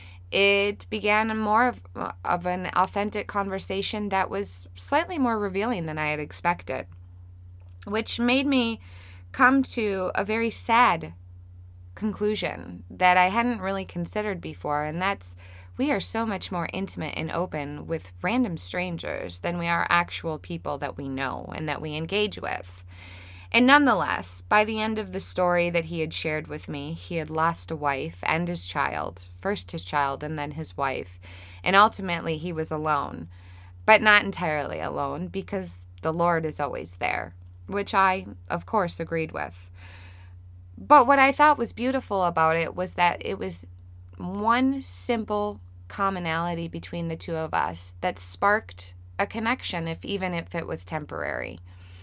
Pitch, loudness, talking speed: 165 Hz, -25 LUFS, 160 wpm